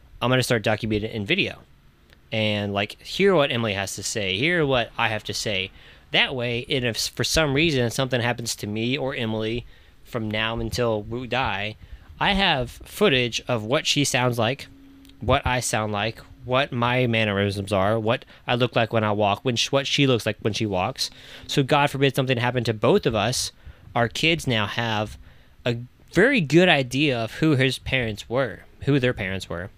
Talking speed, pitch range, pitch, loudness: 195 wpm, 105-130 Hz, 115 Hz, -23 LUFS